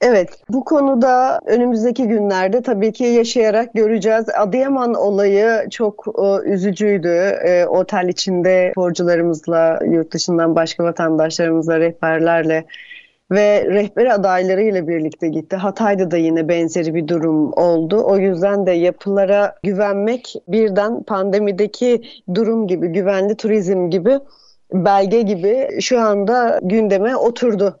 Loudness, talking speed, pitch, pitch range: -16 LUFS, 115 wpm, 200 Hz, 175-220 Hz